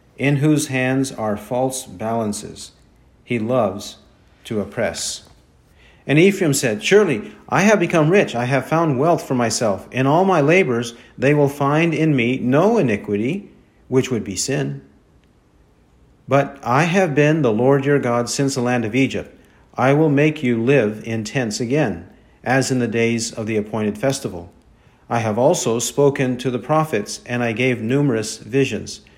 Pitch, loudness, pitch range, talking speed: 130 Hz, -18 LUFS, 115-145 Hz, 165 wpm